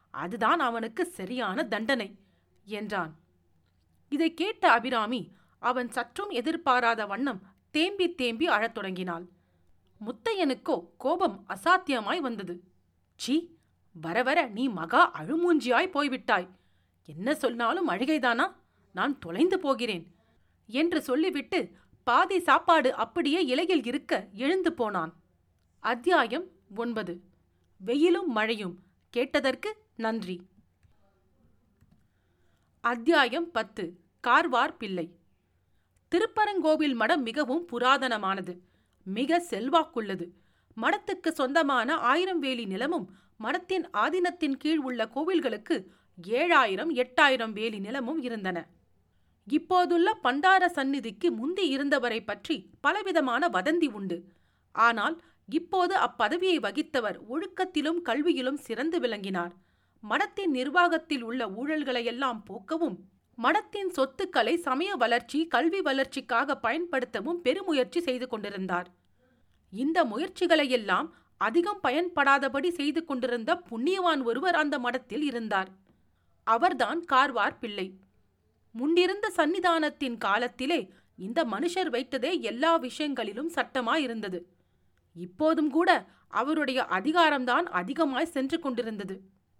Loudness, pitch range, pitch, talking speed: -28 LUFS, 210-330 Hz, 265 Hz, 90 wpm